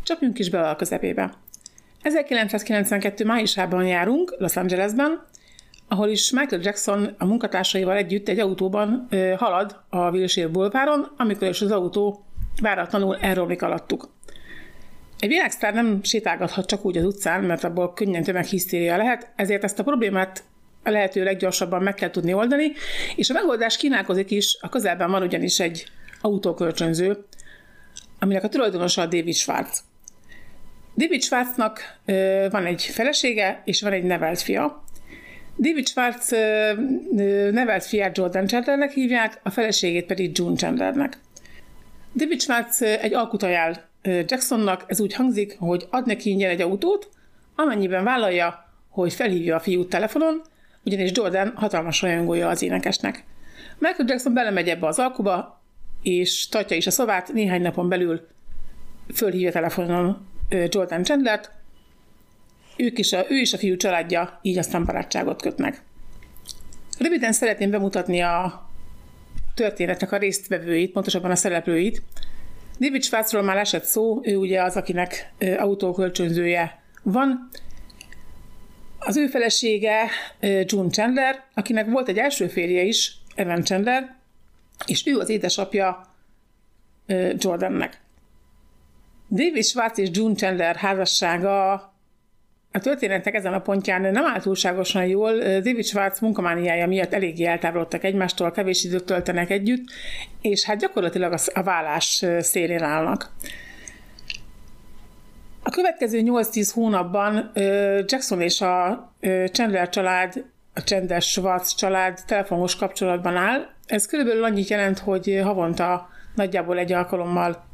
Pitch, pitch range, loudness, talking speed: 195 Hz, 180-220 Hz, -22 LUFS, 125 wpm